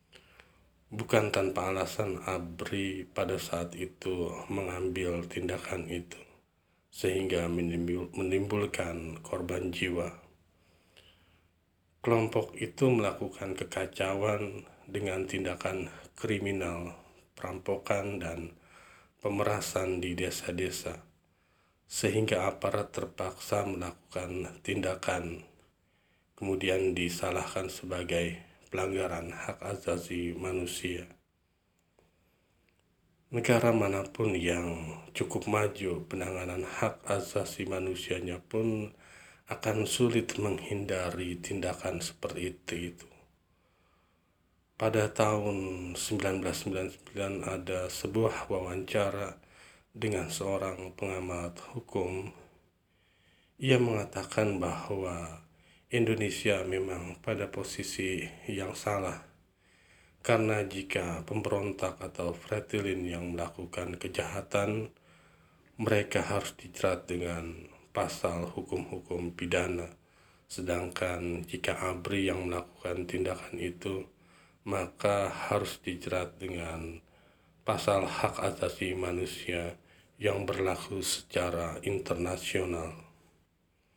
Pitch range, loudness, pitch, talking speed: 85-100 Hz, -33 LUFS, 90 Hz, 75 wpm